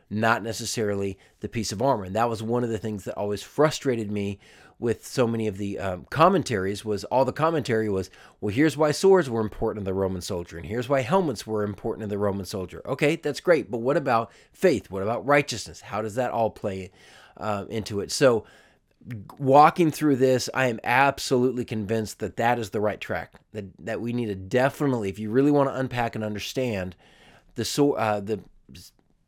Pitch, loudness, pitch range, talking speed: 110 Hz, -25 LUFS, 105-130 Hz, 200 wpm